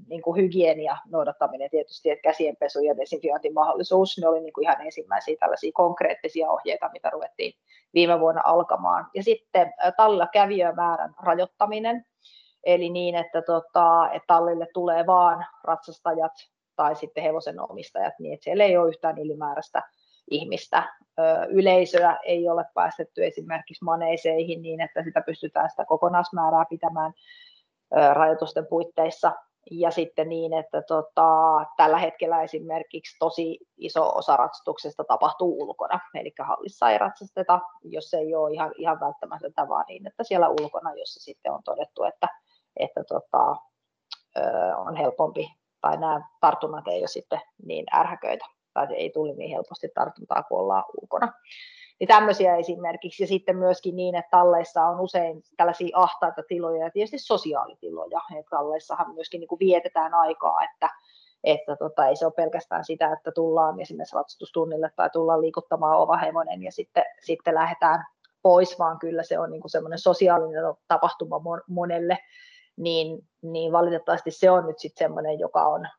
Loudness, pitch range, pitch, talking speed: -24 LUFS, 160-190 Hz, 170 Hz, 145 wpm